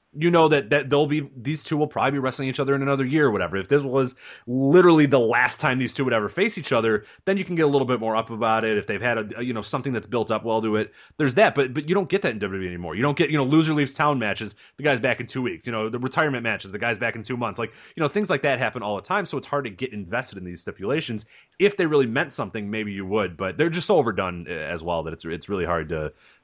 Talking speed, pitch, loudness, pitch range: 305 wpm, 130 Hz, -23 LUFS, 110-150 Hz